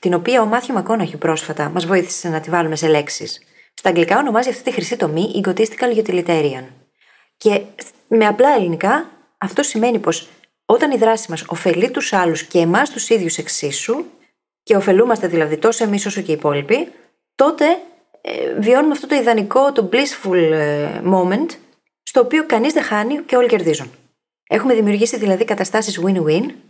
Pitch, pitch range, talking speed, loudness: 205 Hz, 170-245 Hz, 165 wpm, -17 LUFS